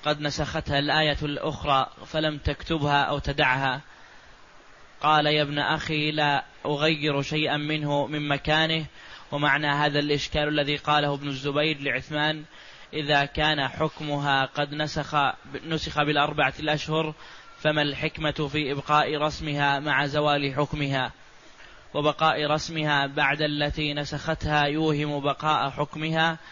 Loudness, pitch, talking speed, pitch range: -25 LUFS, 150 Hz, 115 wpm, 145-155 Hz